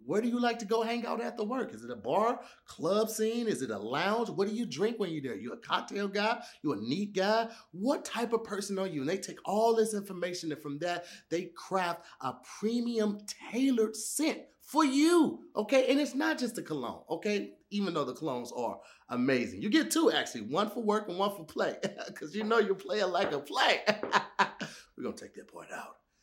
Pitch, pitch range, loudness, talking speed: 210 Hz, 180-235 Hz, -32 LUFS, 225 wpm